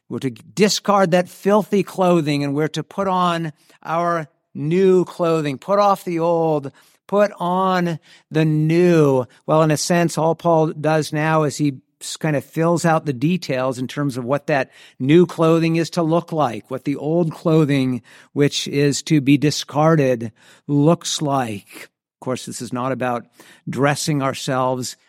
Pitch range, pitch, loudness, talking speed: 140-170 Hz, 155 Hz, -19 LUFS, 165 wpm